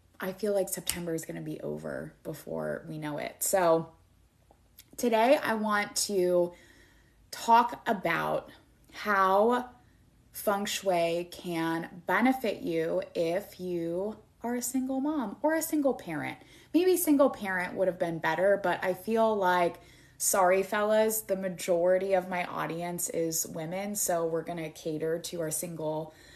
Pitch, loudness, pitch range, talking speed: 185 Hz, -29 LUFS, 165-210 Hz, 145 wpm